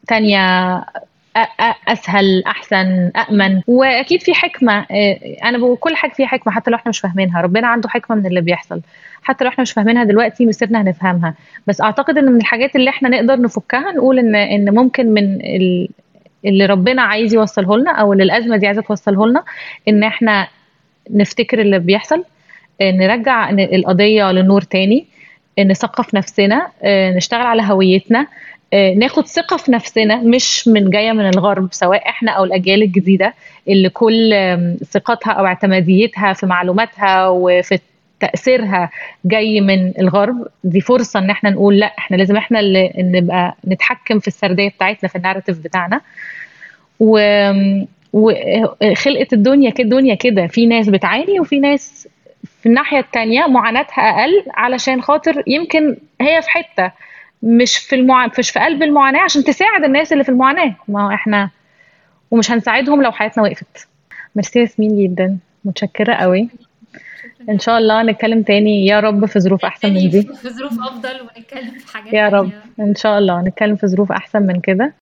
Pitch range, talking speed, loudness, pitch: 195-245 Hz, 150 wpm, -13 LUFS, 215 Hz